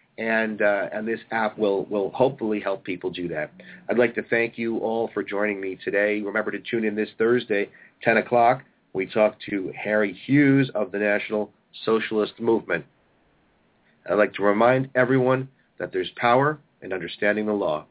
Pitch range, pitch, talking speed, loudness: 105-115 Hz, 110 Hz, 175 wpm, -24 LUFS